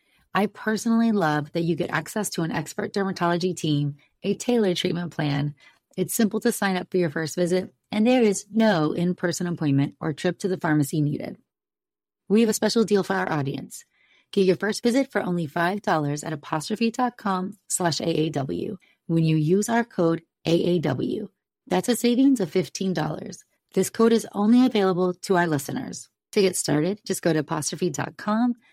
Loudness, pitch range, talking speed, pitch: -24 LUFS, 165-215 Hz, 170 wpm, 185 Hz